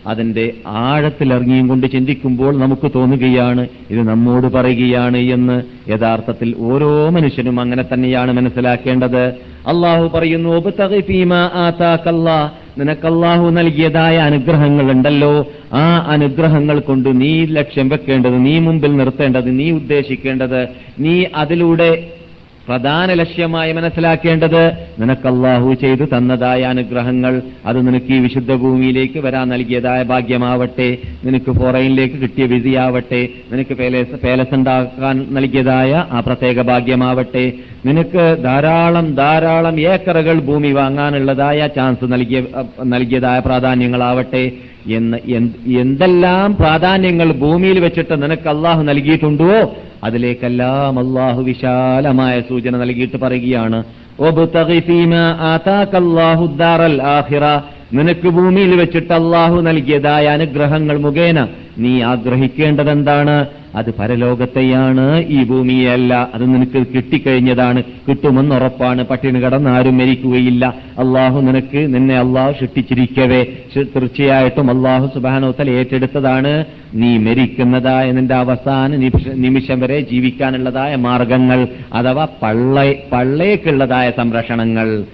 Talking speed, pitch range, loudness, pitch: 90 wpm, 125-150 Hz, -13 LUFS, 130 Hz